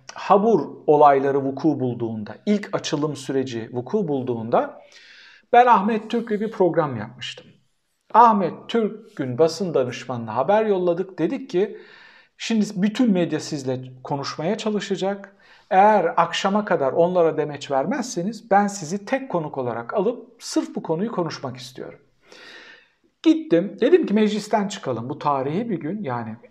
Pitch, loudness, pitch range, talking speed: 180 Hz, -22 LUFS, 140-220 Hz, 130 wpm